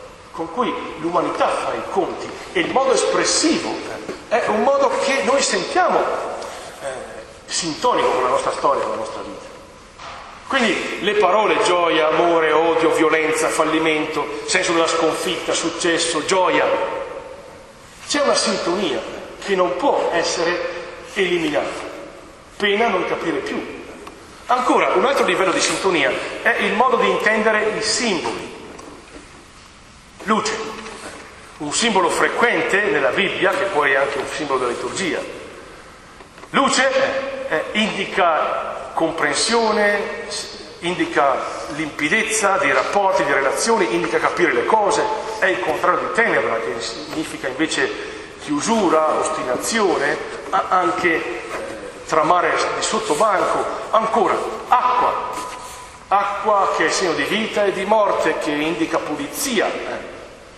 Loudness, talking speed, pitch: -19 LUFS, 120 wpm, 220 Hz